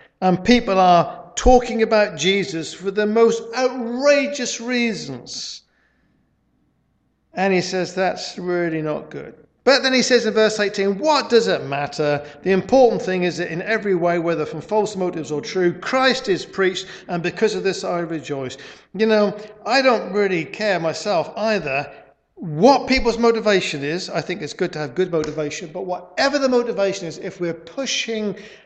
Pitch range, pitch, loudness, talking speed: 175-230 Hz, 195 Hz, -20 LUFS, 170 wpm